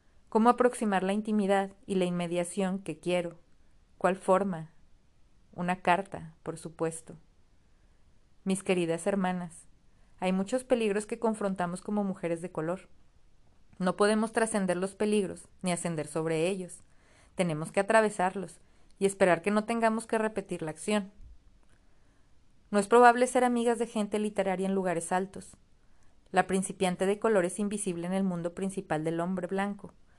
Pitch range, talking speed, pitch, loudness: 175-210 Hz, 145 wpm, 190 Hz, -30 LUFS